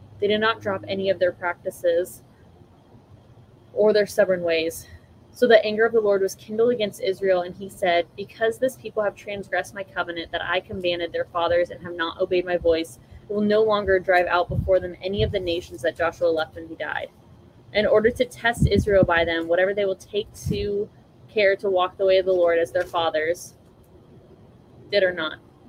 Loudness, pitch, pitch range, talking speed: -23 LUFS, 180 Hz, 165-200 Hz, 200 wpm